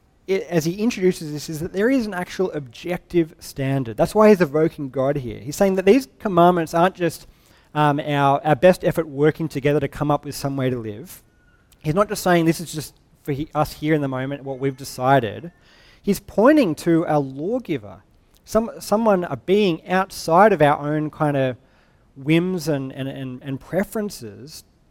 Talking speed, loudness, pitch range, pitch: 190 wpm, -21 LUFS, 135-180 Hz, 155 Hz